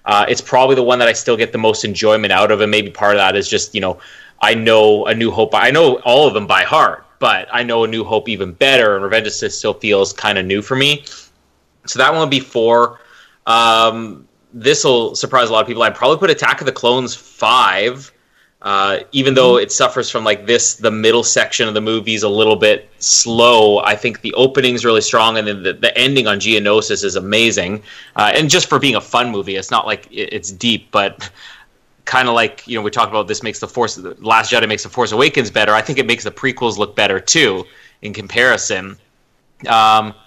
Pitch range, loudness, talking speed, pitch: 105-125 Hz, -13 LUFS, 230 wpm, 110 Hz